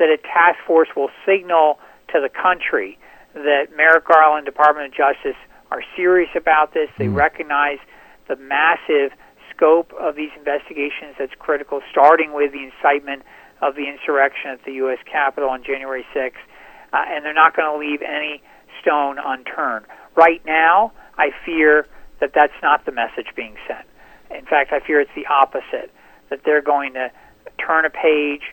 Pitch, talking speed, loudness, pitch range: 150 Hz, 165 wpm, -17 LUFS, 140-160 Hz